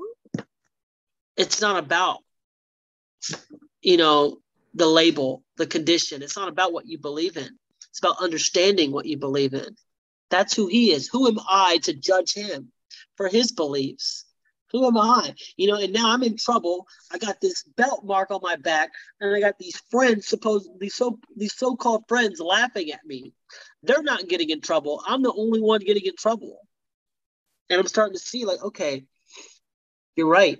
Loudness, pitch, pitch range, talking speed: -22 LUFS, 200 Hz, 165-230 Hz, 175 wpm